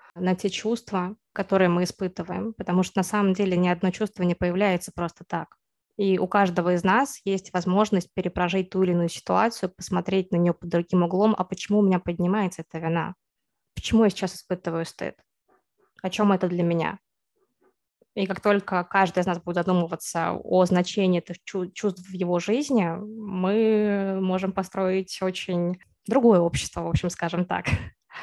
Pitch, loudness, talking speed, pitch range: 185 Hz, -25 LUFS, 165 wpm, 175-200 Hz